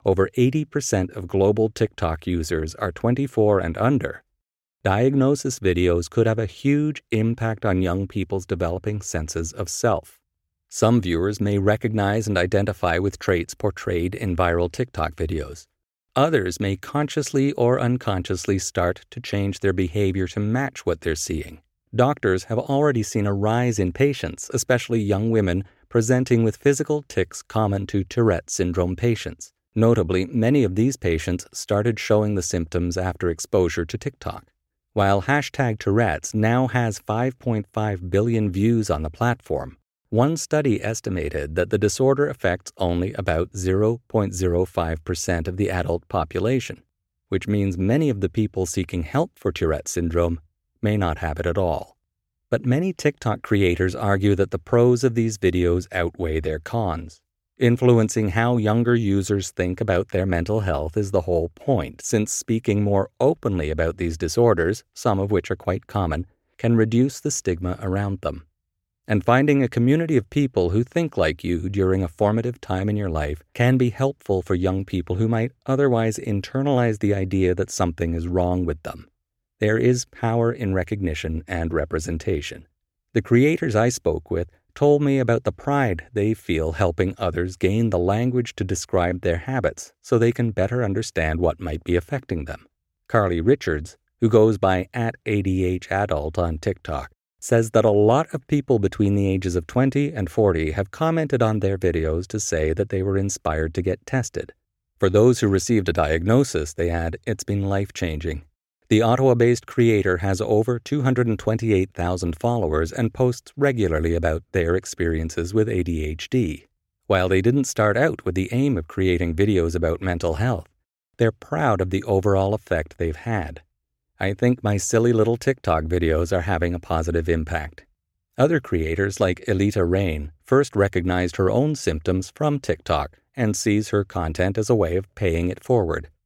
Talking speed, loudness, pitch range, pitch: 160 wpm, -22 LUFS, 90-115 Hz, 100 Hz